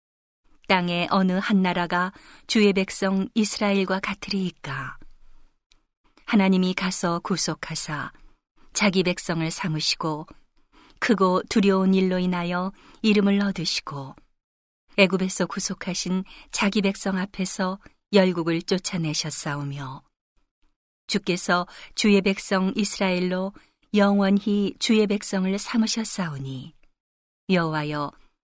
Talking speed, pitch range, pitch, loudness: 235 characters per minute, 175-200 Hz, 190 Hz, -23 LUFS